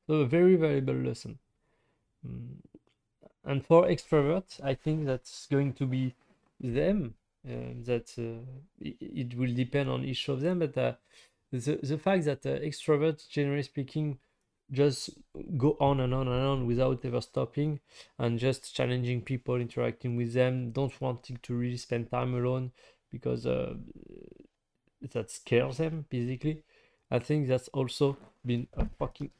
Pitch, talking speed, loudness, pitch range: 130 Hz, 150 wpm, -31 LUFS, 125-150 Hz